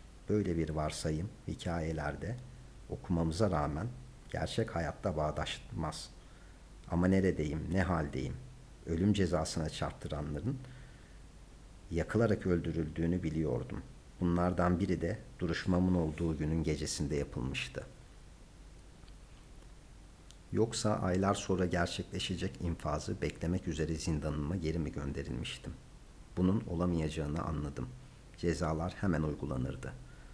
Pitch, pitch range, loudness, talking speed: 85 Hz, 80-95 Hz, -35 LUFS, 85 wpm